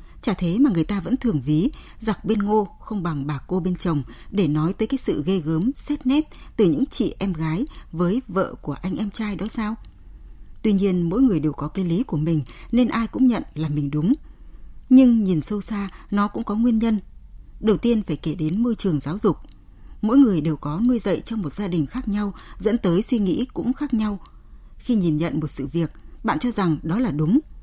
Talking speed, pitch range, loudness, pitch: 230 wpm, 160-230 Hz, -22 LUFS, 200 Hz